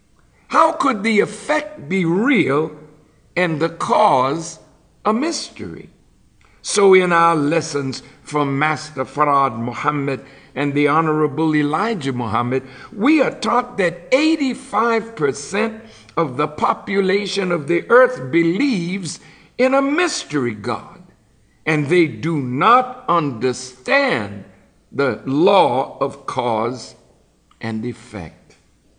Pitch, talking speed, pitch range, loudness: 160 Hz, 105 wpm, 135-220 Hz, -18 LUFS